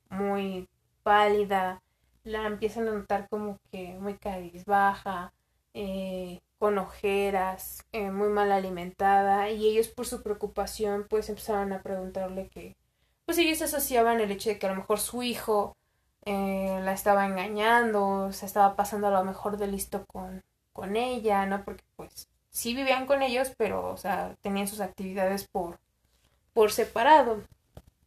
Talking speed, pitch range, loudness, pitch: 150 wpm, 195-215 Hz, -28 LUFS, 200 Hz